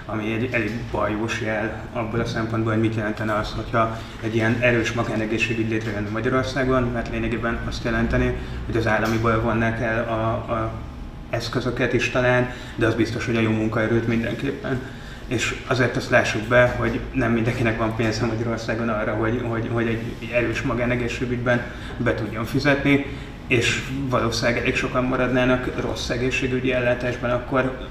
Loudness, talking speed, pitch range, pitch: -23 LUFS, 150 wpm, 110-125 Hz, 115 Hz